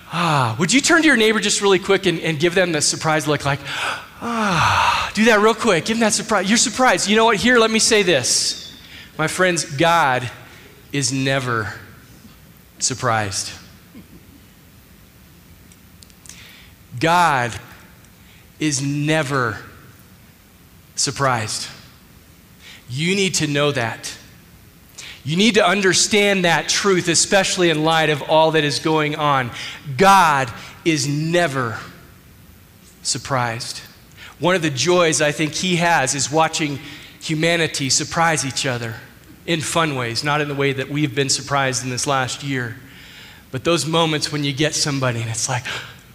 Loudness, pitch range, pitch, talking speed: -18 LUFS, 125-170 Hz, 150 Hz, 145 wpm